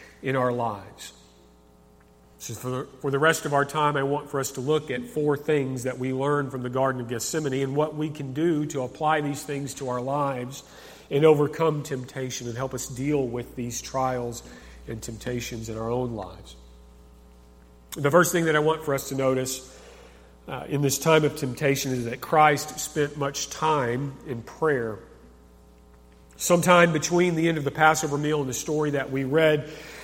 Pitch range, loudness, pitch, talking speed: 120-150 Hz, -25 LUFS, 135 Hz, 190 wpm